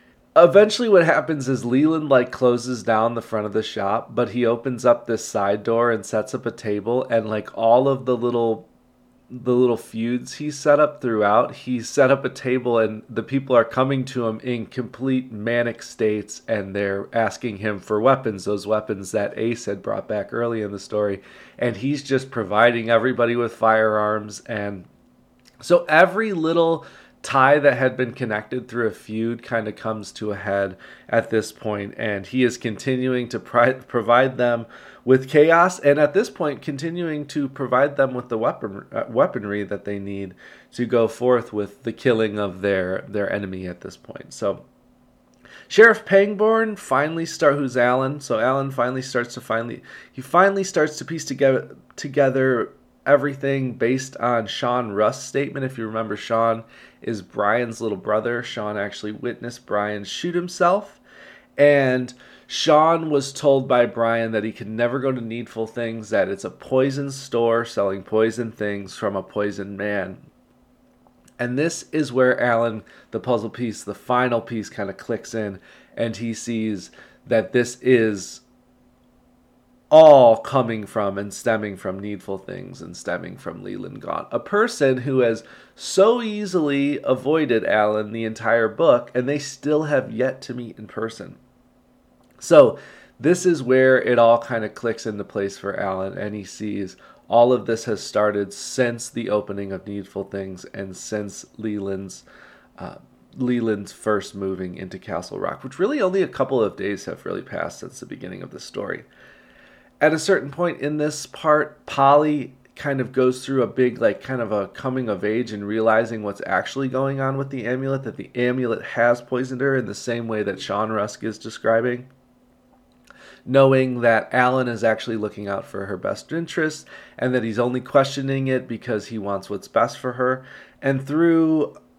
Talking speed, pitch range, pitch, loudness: 175 wpm, 110-135 Hz, 120 Hz, -21 LUFS